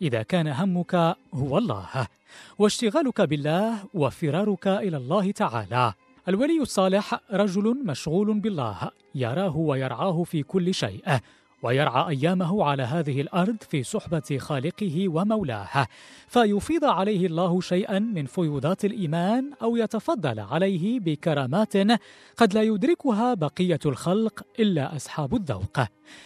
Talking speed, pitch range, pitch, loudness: 110 wpm, 150-210 Hz, 185 Hz, -25 LUFS